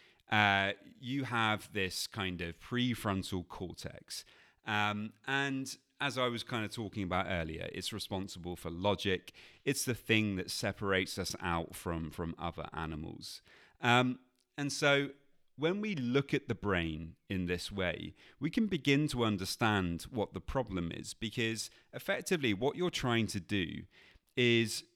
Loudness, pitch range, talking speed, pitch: -35 LUFS, 95-125 Hz, 150 wpm, 105 Hz